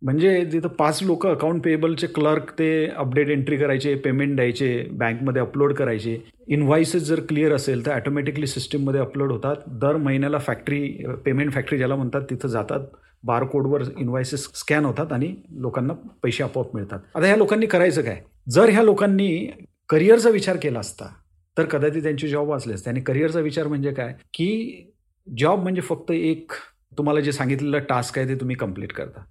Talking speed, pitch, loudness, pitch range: 165 wpm, 145 Hz, -22 LUFS, 130-155 Hz